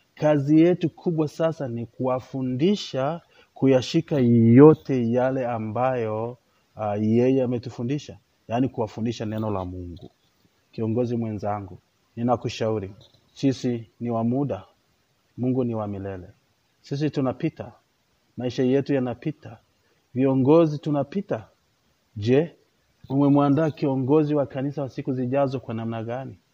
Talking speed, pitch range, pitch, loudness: 105 wpm, 115-140 Hz, 125 Hz, -23 LUFS